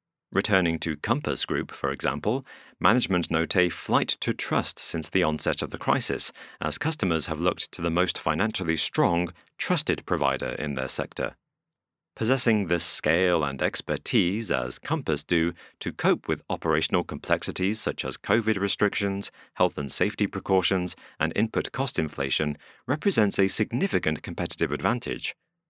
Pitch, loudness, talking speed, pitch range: 90 Hz, -26 LUFS, 145 wpm, 80-105 Hz